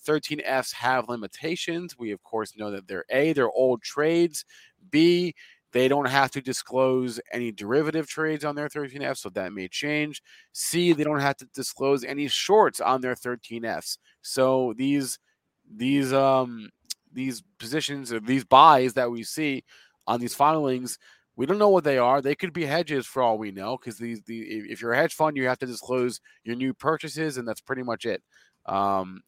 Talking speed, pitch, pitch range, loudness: 185 wpm, 130 Hz, 120-150 Hz, -25 LUFS